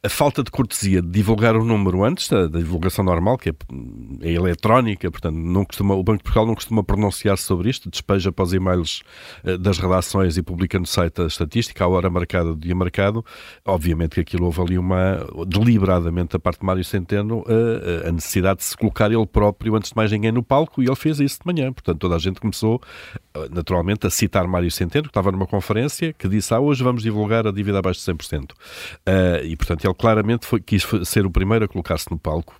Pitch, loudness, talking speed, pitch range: 95 Hz, -20 LUFS, 215 wpm, 90-110 Hz